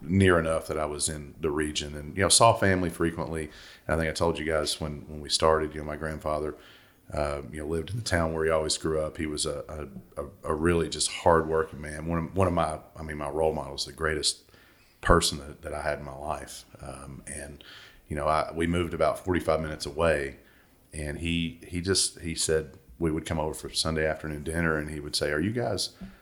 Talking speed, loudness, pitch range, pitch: 235 wpm, -28 LUFS, 75-85 Hz, 80 Hz